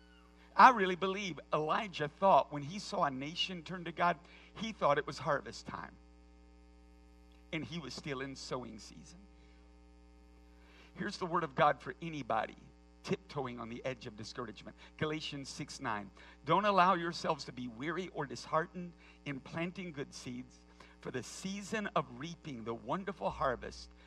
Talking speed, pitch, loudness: 155 wpm, 140 Hz, -35 LUFS